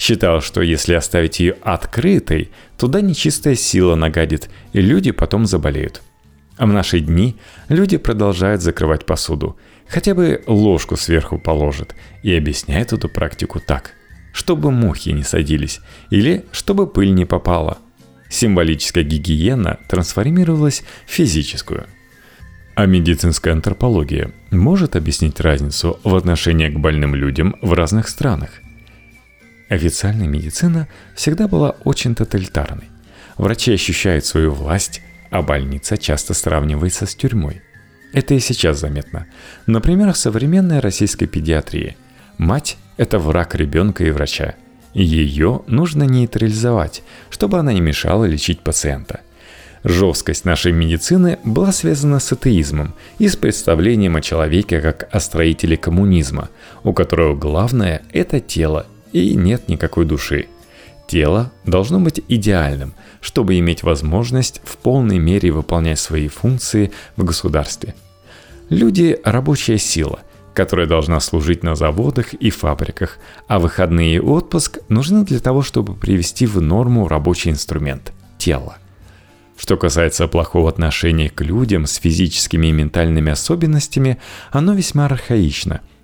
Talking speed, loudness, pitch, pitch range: 125 wpm, -16 LUFS, 90 Hz, 80-115 Hz